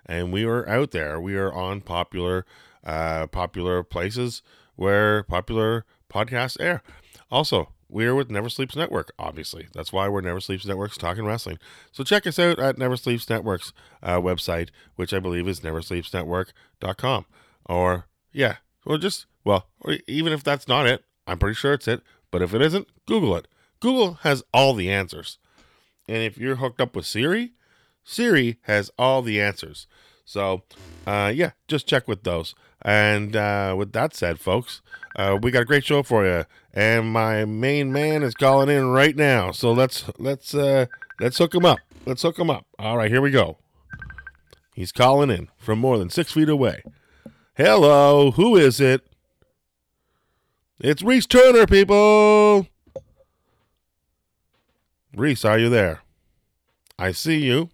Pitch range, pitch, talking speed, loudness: 95-140 Hz, 115 Hz, 165 wpm, -21 LUFS